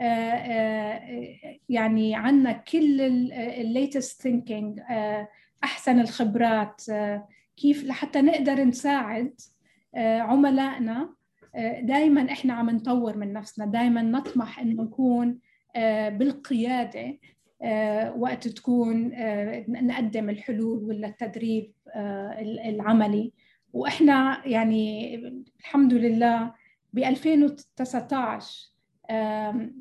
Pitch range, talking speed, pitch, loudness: 220-260 Hz, 95 wpm, 235 Hz, -25 LUFS